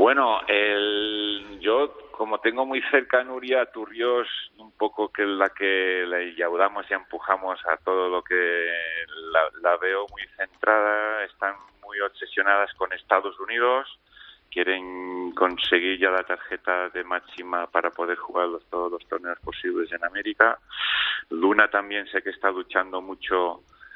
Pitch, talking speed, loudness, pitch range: 95 Hz, 150 wpm, -24 LUFS, 90-105 Hz